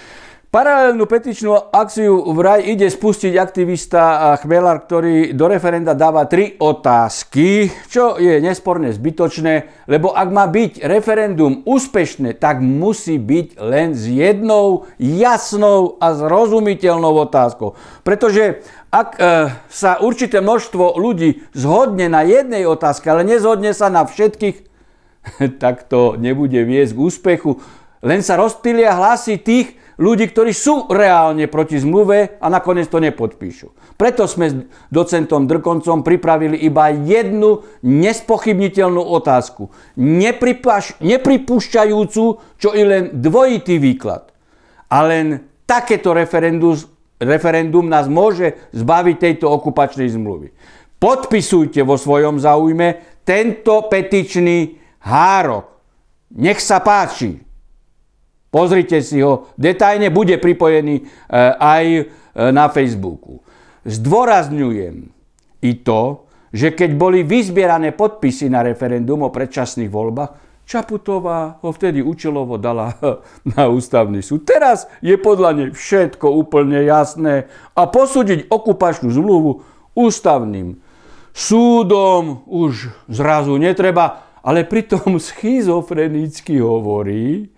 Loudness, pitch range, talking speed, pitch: -14 LUFS, 145-205 Hz, 110 wpm, 170 Hz